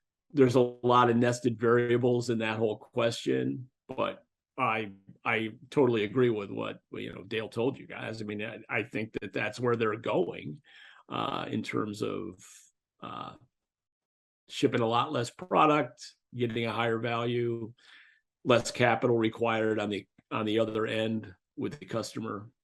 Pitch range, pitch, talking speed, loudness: 110-120 Hz, 115 Hz, 155 wpm, -30 LUFS